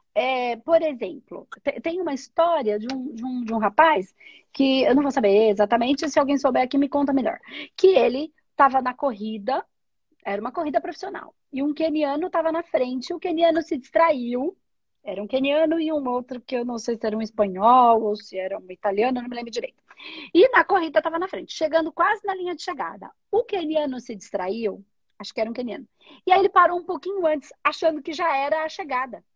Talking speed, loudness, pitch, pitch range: 210 wpm, -23 LUFS, 285 Hz, 245-330 Hz